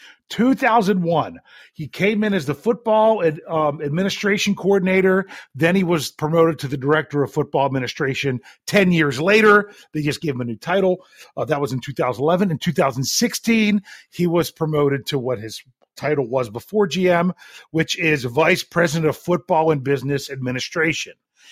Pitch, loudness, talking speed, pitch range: 160 Hz, -19 LUFS, 160 wpm, 140-190 Hz